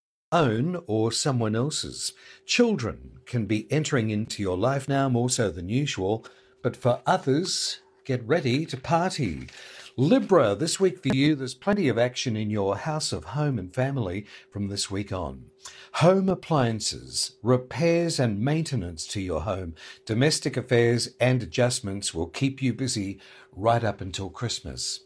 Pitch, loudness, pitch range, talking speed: 125 Hz, -26 LUFS, 105-150 Hz, 150 wpm